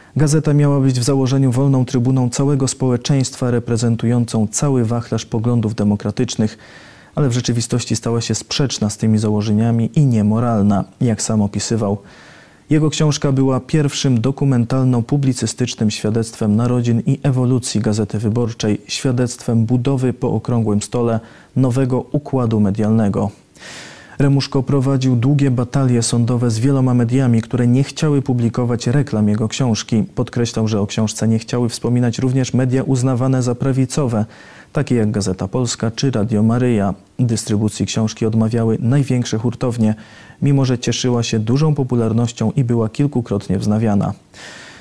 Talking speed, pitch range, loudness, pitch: 130 wpm, 110-130 Hz, -17 LUFS, 120 Hz